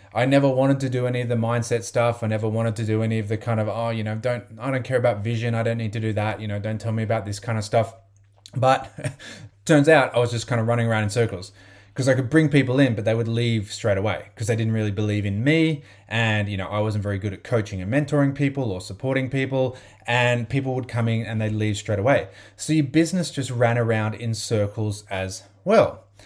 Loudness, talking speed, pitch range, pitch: -23 LUFS, 255 wpm, 105-125 Hz, 115 Hz